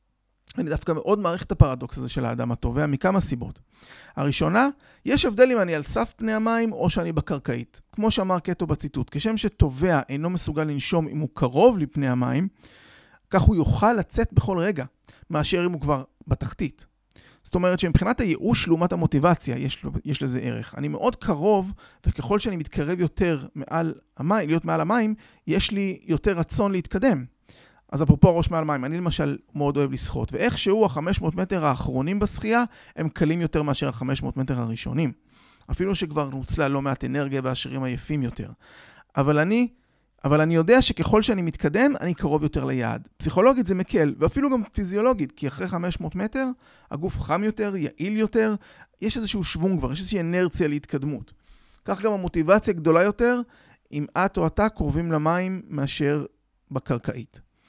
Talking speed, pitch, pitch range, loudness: 160 wpm, 165 Hz, 145-200 Hz, -24 LUFS